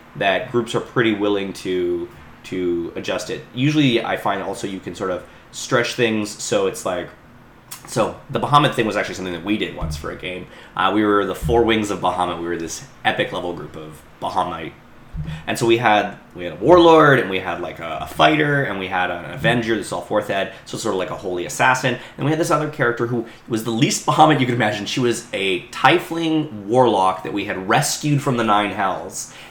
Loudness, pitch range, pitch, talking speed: -19 LUFS, 90-130 Hz, 110 Hz, 225 wpm